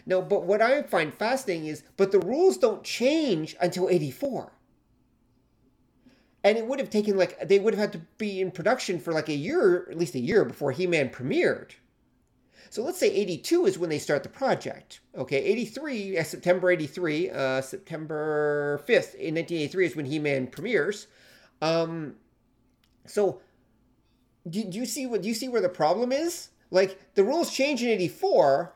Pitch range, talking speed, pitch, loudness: 150-225 Hz, 170 wpm, 180 Hz, -26 LUFS